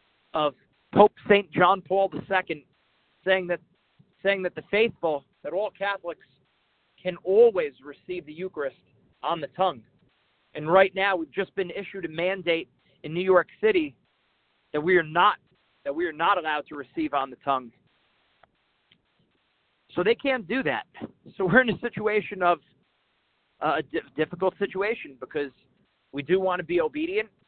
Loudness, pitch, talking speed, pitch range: -26 LUFS, 185 Hz, 155 wpm, 165-205 Hz